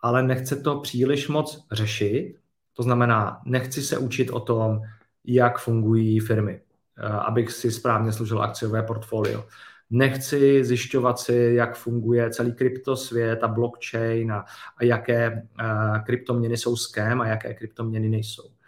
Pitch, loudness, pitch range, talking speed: 120 Hz, -24 LUFS, 110-125 Hz, 130 wpm